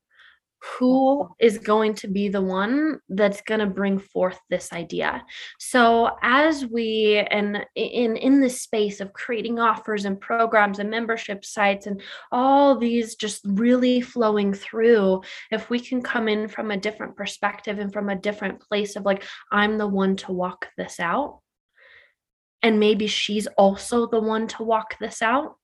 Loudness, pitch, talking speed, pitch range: -22 LUFS, 215 Hz, 165 wpm, 205-235 Hz